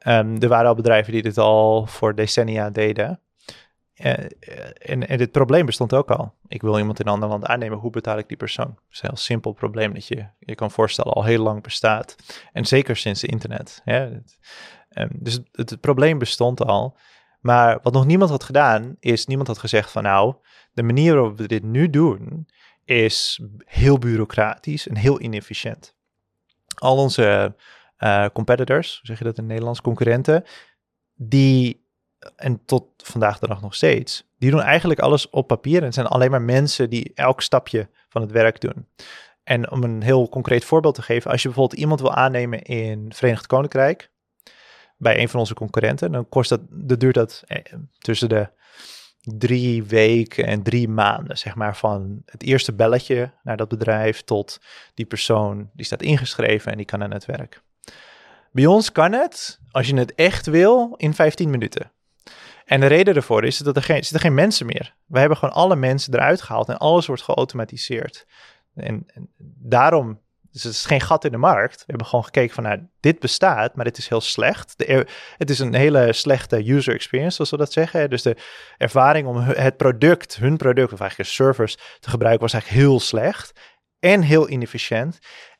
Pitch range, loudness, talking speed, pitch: 110-140 Hz, -19 LUFS, 190 wpm, 120 Hz